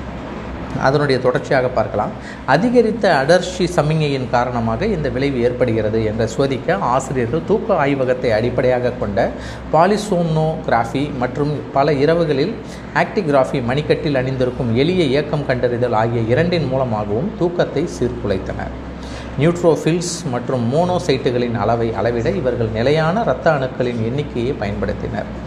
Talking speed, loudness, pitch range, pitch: 100 wpm, -18 LUFS, 120-165 Hz, 135 Hz